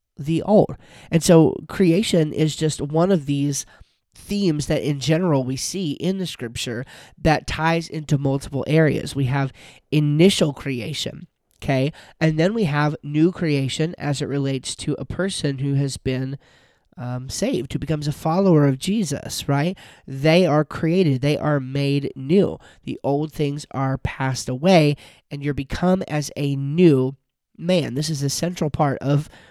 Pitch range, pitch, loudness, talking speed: 135-165 Hz, 145 Hz, -21 LUFS, 160 wpm